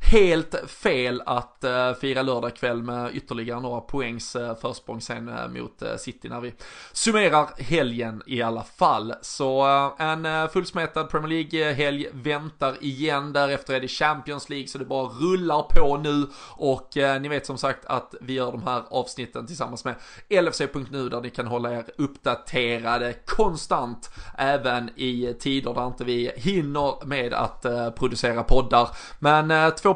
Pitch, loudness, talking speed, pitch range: 135 Hz, -25 LUFS, 145 wpm, 120-145 Hz